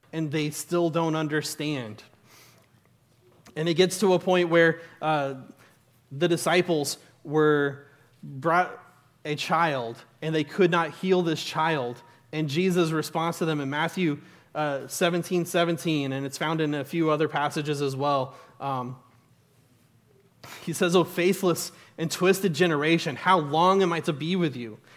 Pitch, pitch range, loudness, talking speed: 155 Hz, 140-170 Hz, -25 LUFS, 150 wpm